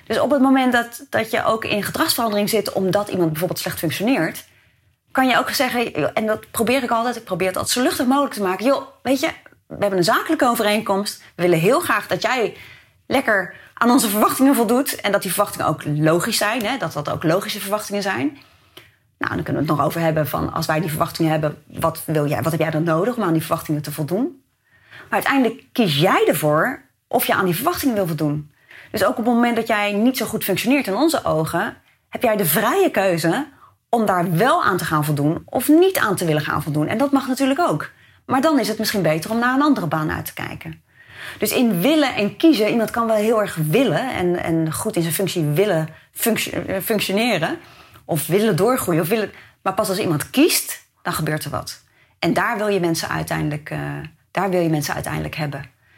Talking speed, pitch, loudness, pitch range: 220 wpm, 200 Hz, -19 LUFS, 160-240 Hz